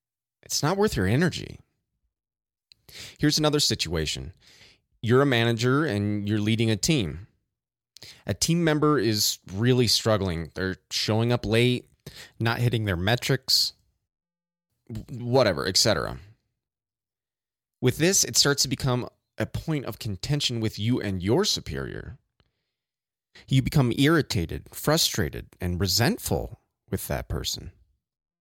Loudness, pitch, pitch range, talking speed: -24 LUFS, 115 Hz, 100-135 Hz, 120 wpm